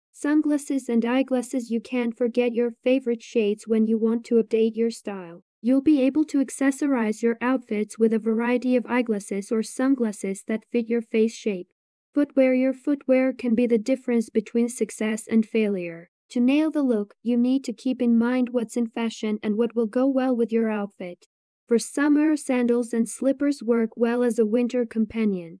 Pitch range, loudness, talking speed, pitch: 225-255 Hz, -24 LUFS, 185 wpm, 235 Hz